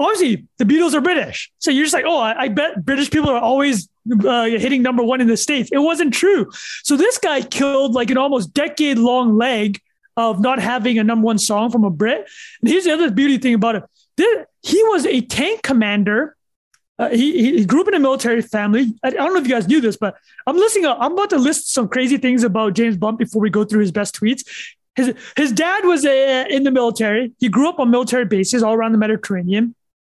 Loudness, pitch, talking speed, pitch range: -17 LUFS, 250 Hz, 235 wpm, 225-295 Hz